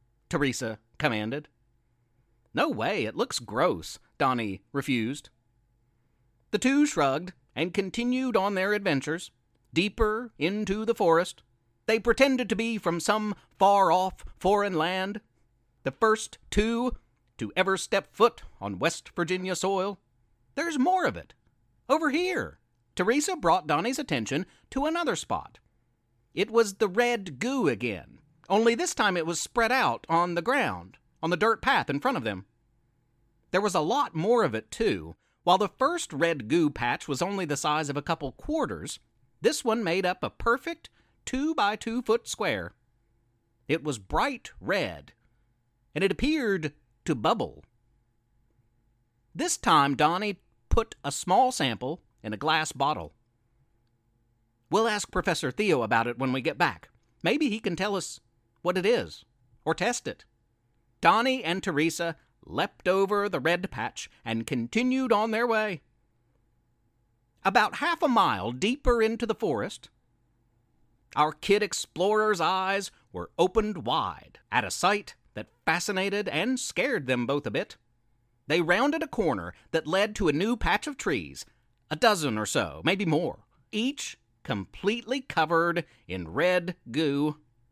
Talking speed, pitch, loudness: 150 wpm, 165 Hz, -27 LUFS